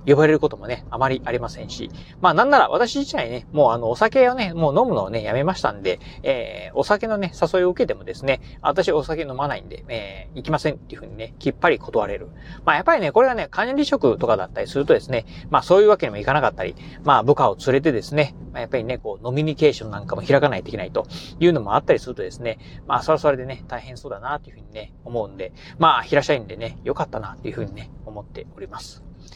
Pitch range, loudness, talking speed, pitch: 120-180 Hz, -21 LUFS, 510 characters per minute, 145 Hz